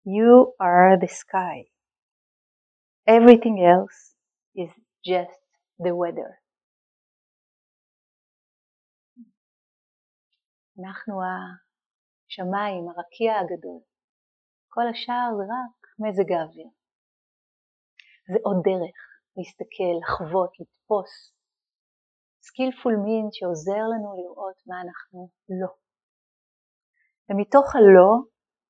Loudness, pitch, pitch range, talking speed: -20 LUFS, 190 Hz, 180-225 Hz, 75 wpm